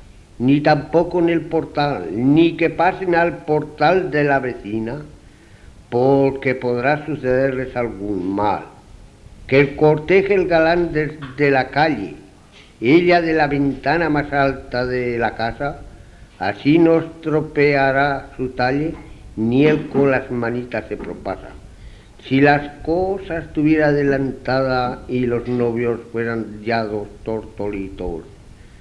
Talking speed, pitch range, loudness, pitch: 125 wpm, 115-150 Hz, -18 LUFS, 135 Hz